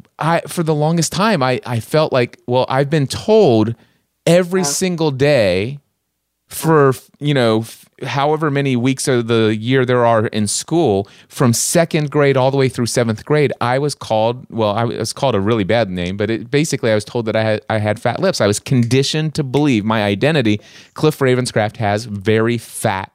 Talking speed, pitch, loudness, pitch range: 195 wpm, 125 Hz, -16 LUFS, 110-150 Hz